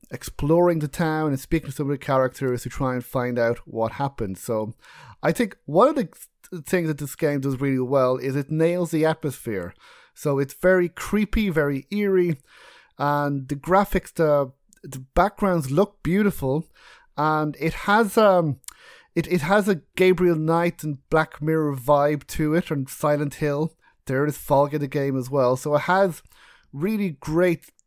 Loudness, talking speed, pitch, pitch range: -23 LUFS, 175 wpm, 150 Hz, 140-175 Hz